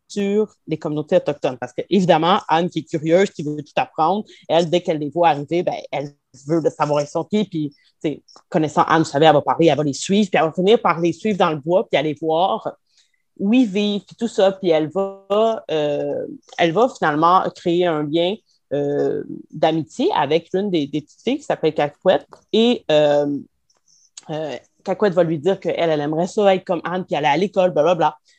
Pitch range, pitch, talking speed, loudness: 155-195 Hz, 170 Hz, 210 wpm, -19 LUFS